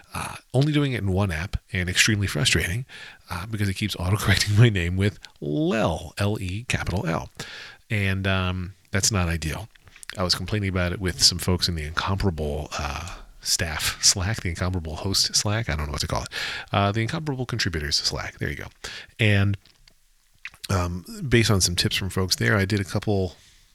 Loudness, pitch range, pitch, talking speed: -24 LUFS, 90-110 Hz, 95 Hz, 185 wpm